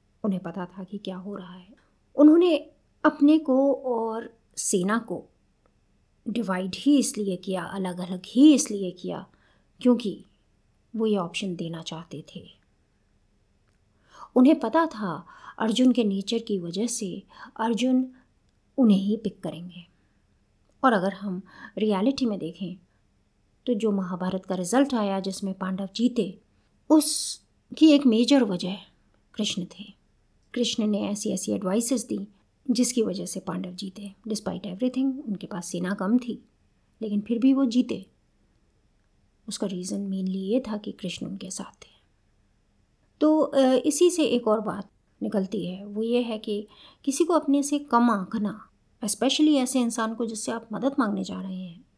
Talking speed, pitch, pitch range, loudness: 145 wpm, 205 Hz, 185-245 Hz, -25 LUFS